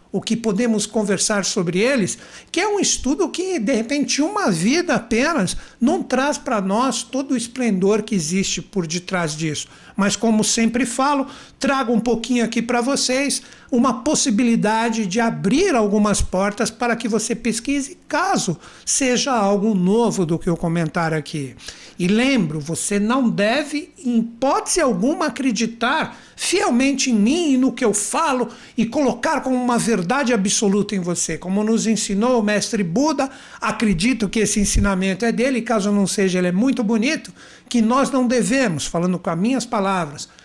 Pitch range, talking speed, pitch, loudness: 205-260 Hz, 165 wpm, 230 Hz, -19 LUFS